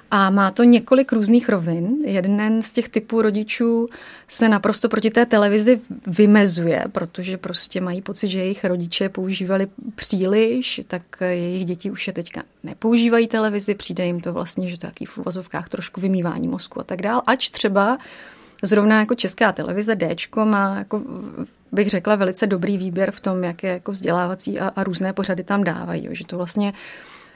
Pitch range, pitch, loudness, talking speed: 185-220 Hz, 200 Hz, -20 LUFS, 170 wpm